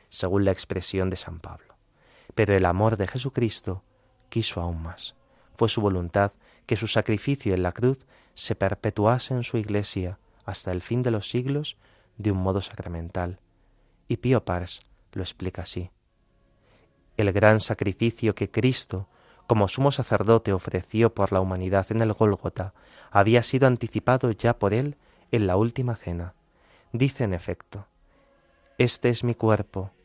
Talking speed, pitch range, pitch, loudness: 150 wpm, 95-120 Hz, 105 Hz, -25 LUFS